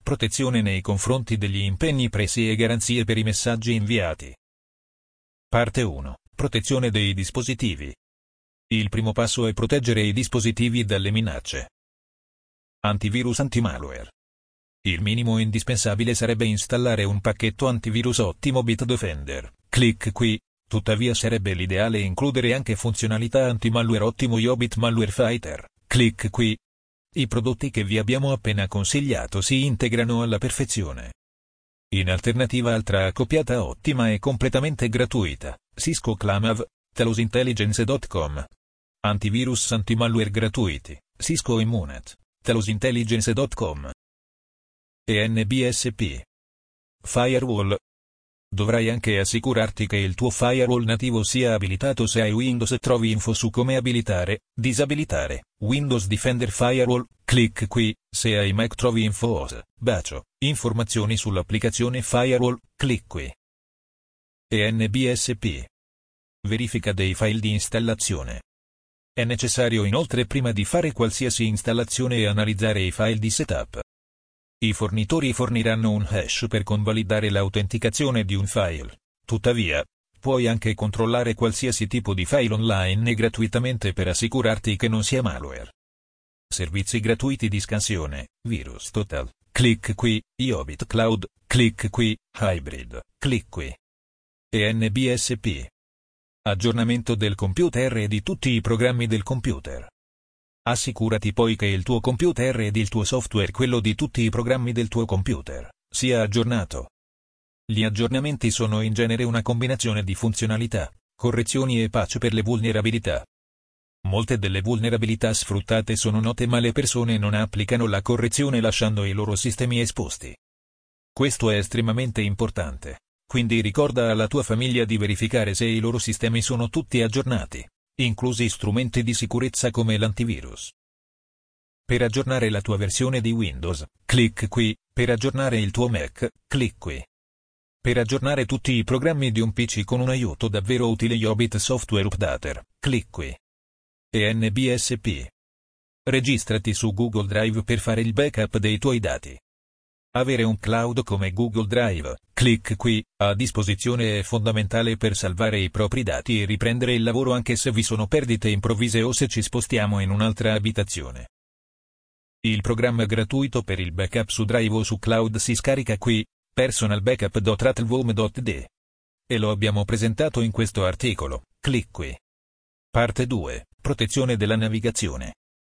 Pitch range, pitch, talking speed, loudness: 105-120 Hz, 115 Hz, 130 wpm, -23 LUFS